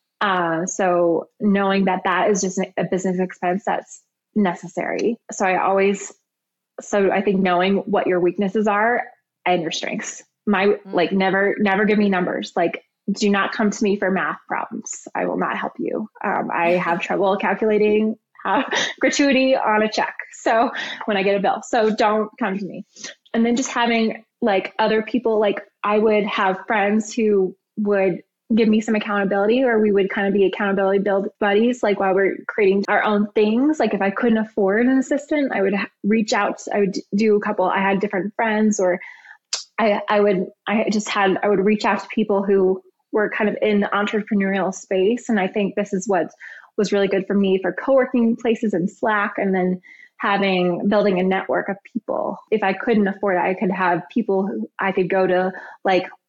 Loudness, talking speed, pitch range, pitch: -20 LUFS, 195 wpm, 190-220 Hz, 205 Hz